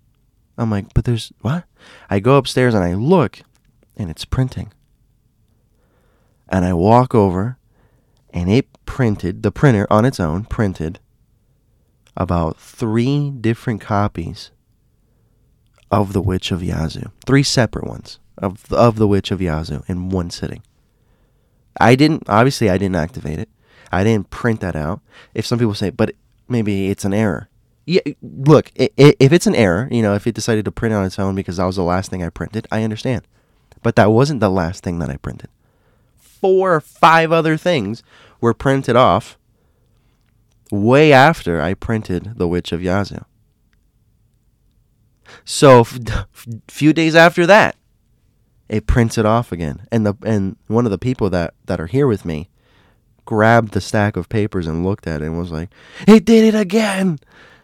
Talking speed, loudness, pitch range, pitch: 165 wpm, -16 LUFS, 95-125 Hz, 110 Hz